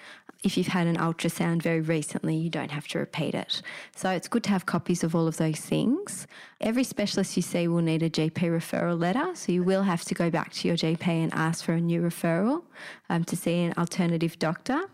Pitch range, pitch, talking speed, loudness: 165-185 Hz, 170 Hz, 225 wpm, -27 LUFS